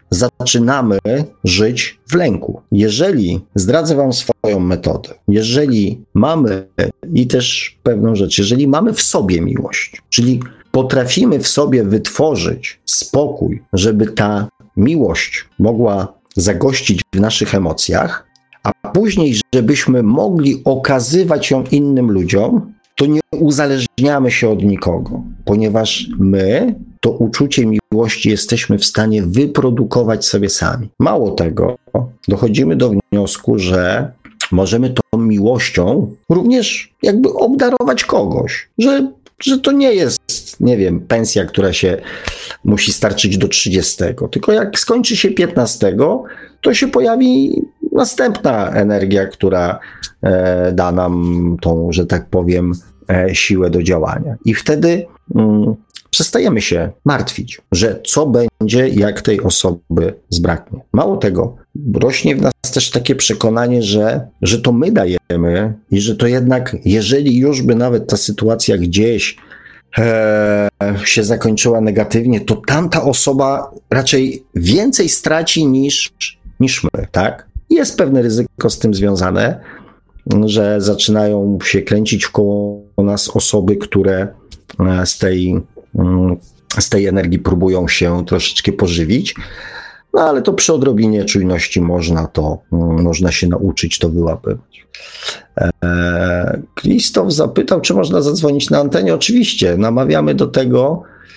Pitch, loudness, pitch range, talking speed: 110 Hz, -14 LUFS, 95-130 Hz, 120 wpm